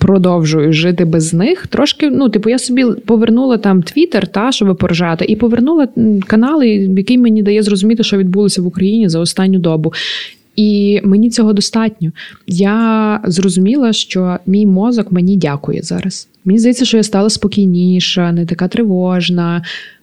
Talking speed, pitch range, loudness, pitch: 150 wpm, 180-225 Hz, -12 LUFS, 200 Hz